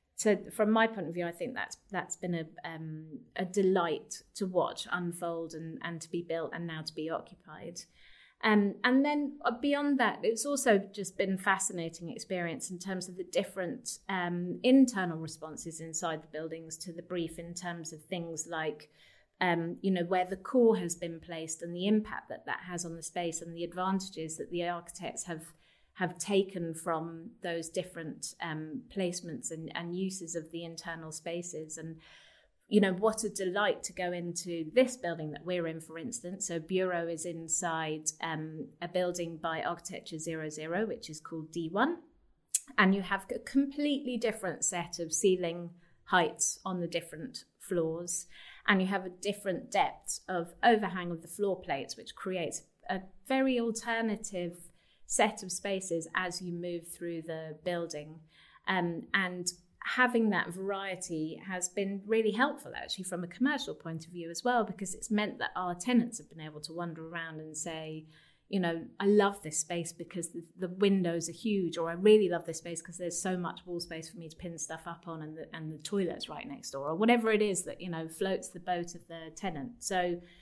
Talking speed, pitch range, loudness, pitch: 190 wpm, 165-195 Hz, -33 LUFS, 175 Hz